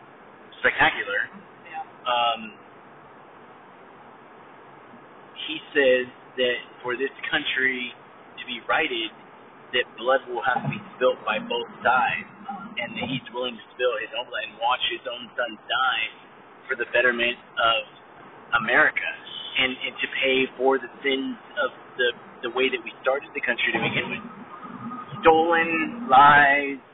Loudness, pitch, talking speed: -23 LUFS, 135 Hz, 135 wpm